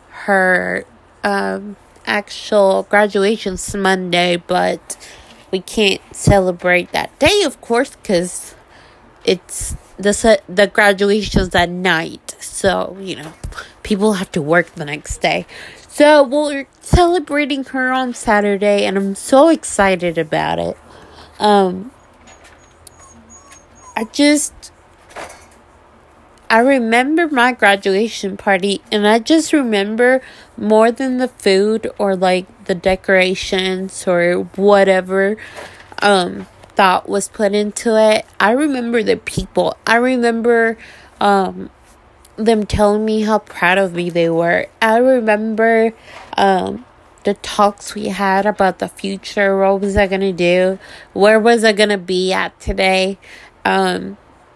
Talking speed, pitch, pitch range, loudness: 120 wpm, 200 Hz, 185-225 Hz, -15 LUFS